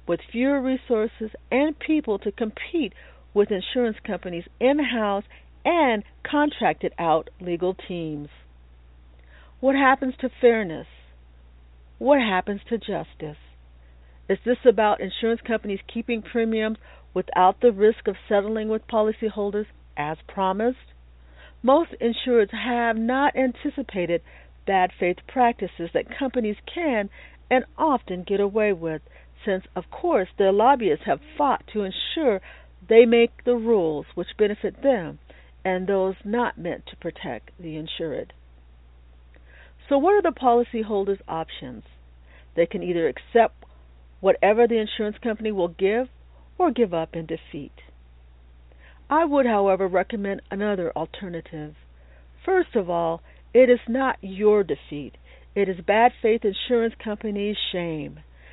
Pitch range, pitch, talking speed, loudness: 160-235 Hz, 205 Hz, 125 wpm, -23 LUFS